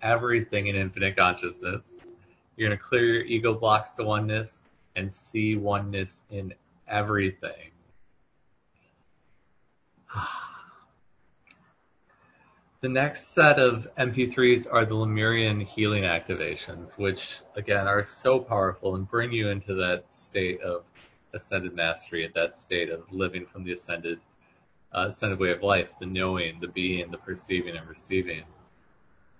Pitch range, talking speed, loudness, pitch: 90-110 Hz, 130 wpm, -27 LUFS, 100 Hz